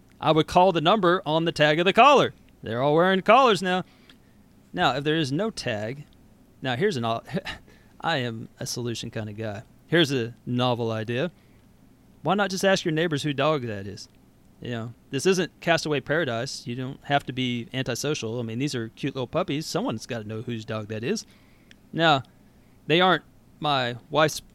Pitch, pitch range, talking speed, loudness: 135 Hz, 115-160 Hz, 190 wpm, -24 LUFS